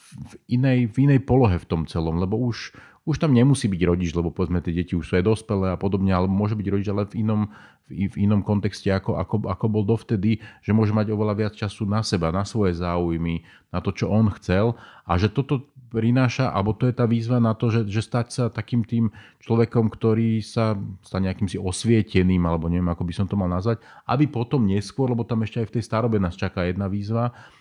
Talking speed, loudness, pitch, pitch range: 220 wpm, -23 LUFS, 105 Hz, 95-115 Hz